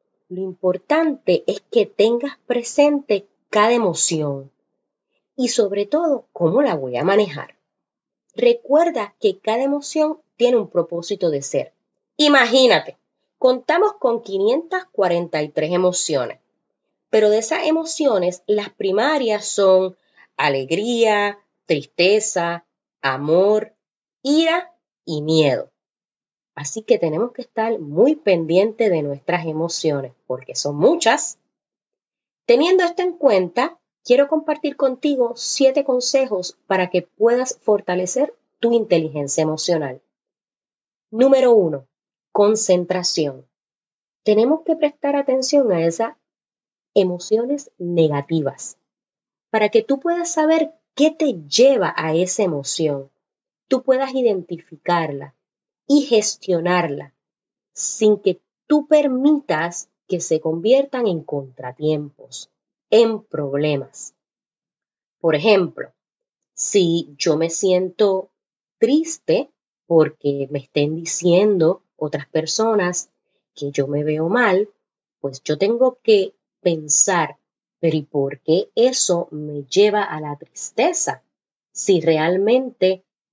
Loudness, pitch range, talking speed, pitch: -19 LUFS, 165-270 Hz, 105 wpm, 205 Hz